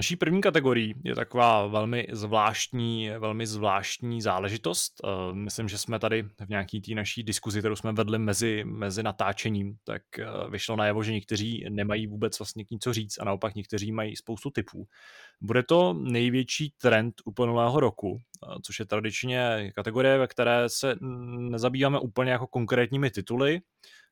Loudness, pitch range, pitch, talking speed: -28 LUFS, 105-125 Hz, 115 Hz, 150 wpm